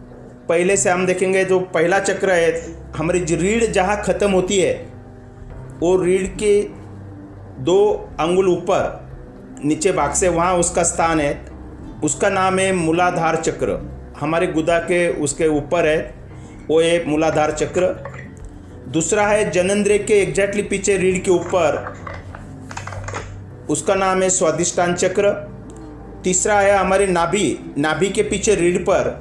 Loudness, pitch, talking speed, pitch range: -18 LUFS, 170 Hz, 135 wpm, 130-190 Hz